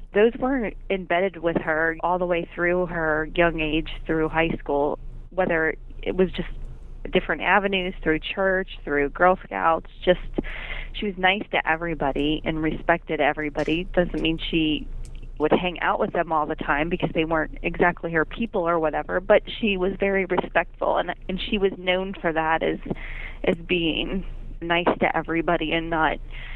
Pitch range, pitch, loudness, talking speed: 160-185 Hz, 170 Hz, -24 LUFS, 165 wpm